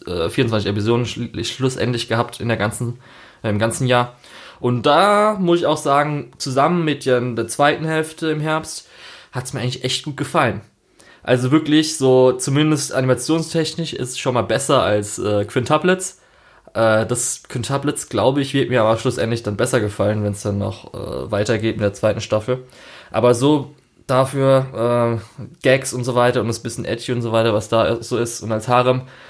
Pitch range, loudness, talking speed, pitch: 115-140 Hz, -19 LUFS, 180 wpm, 125 Hz